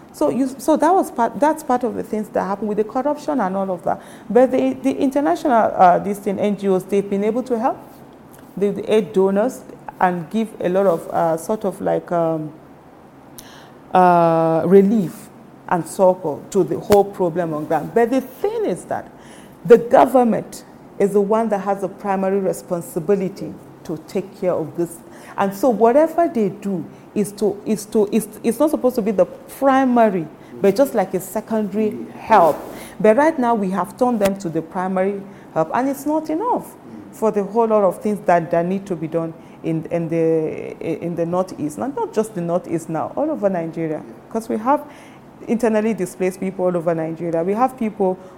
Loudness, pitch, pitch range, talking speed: -19 LUFS, 200 Hz, 180-235 Hz, 190 wpm